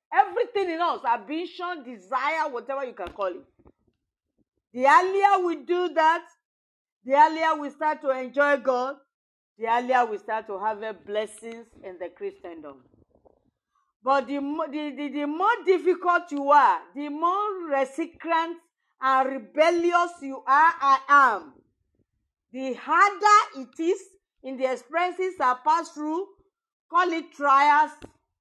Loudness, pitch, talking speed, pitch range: -24 LUFS, 300 Hz, 135 wpm, 260-345 Hz